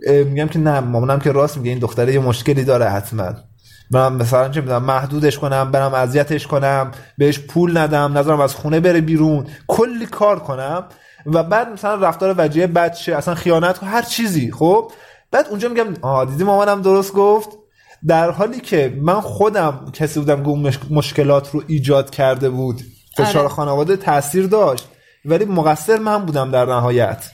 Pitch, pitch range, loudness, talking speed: 150 Hz, 135-180 Hz, -16 LUFS, 170 wpm